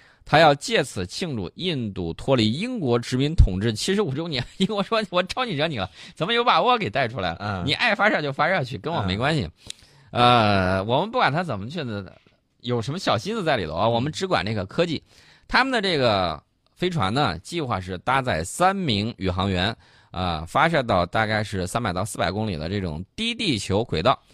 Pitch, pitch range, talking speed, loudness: 115 Hz, 95-160 Hz, 305 characters per minute, -23 LUFS